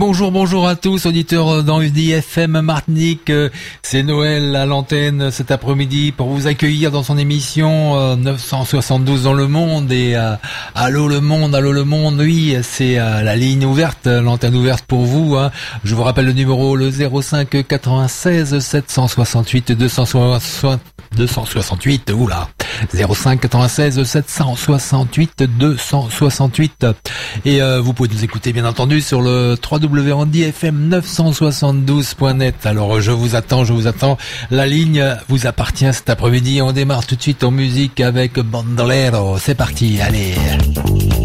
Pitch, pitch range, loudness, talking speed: 135 Hz, 120-145 Hz, -14 LUFS, 140 wpm